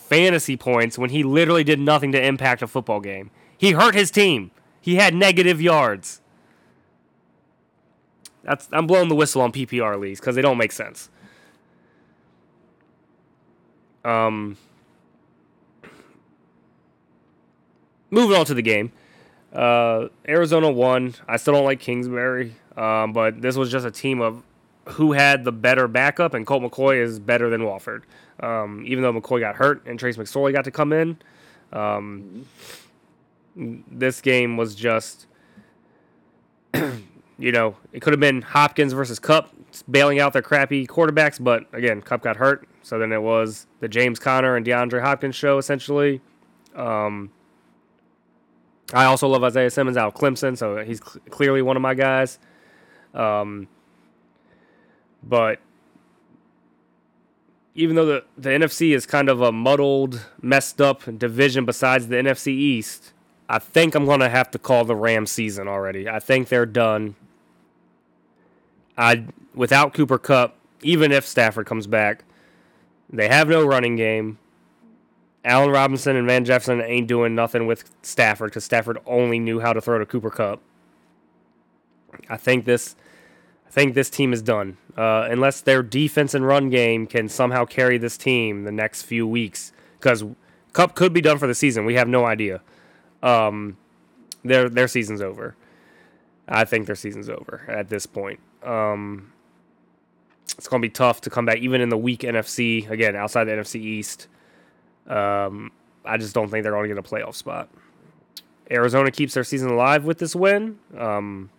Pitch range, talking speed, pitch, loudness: 105-135 Hz, 155 wpm, 120 Hz, -20 LUFS